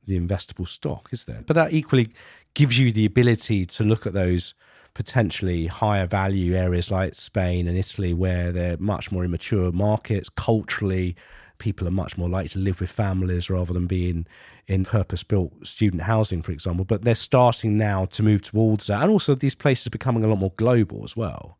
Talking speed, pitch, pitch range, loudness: 190 wpm, 100 Hz, 90-110 Hz, -23 LUFS